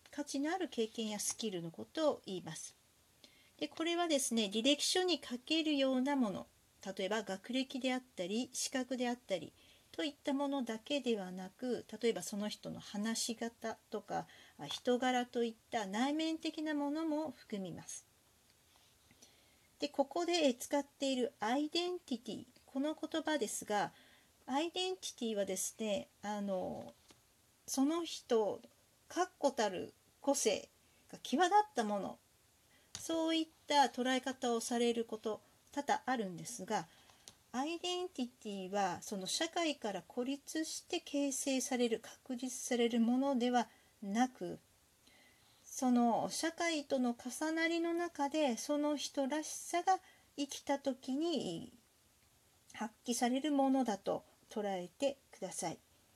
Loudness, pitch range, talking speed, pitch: -38 LUFS, 225-295 Hz, 265 characters per minute, 260 Hz